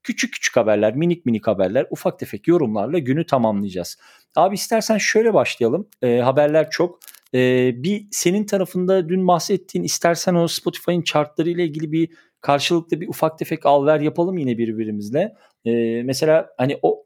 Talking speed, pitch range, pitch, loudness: 155 wpm, 125-180 Hz, 165 Hz, -20 LUFS